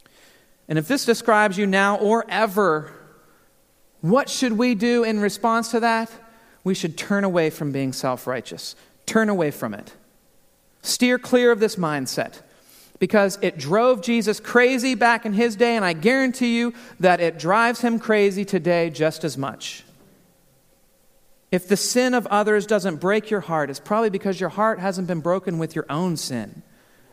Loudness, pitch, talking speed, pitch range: -21 LUFS, 205 Hz, 170 wpm, 175-235 Hz